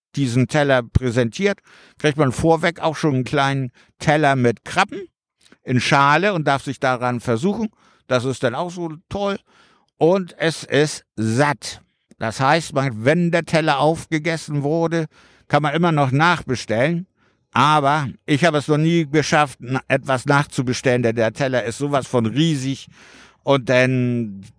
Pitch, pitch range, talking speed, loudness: 145 Hz, 130-160 Hz, 145 wpm, -19 LUFS